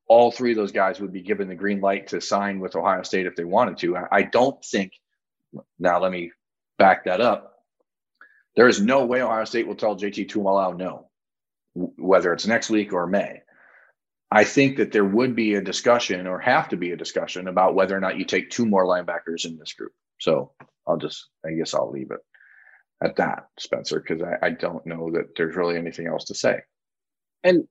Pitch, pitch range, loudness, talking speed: 95 Hz, 90-110 Hz, -23 LUFS, 210 wpm